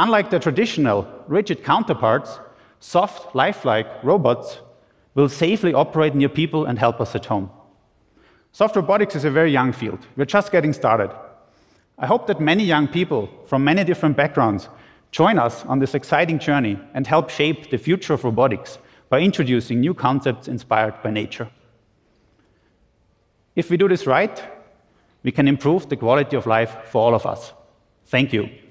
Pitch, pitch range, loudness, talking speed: 140 Hz, 115-160 Hz, -20 LUFS, 160 wpm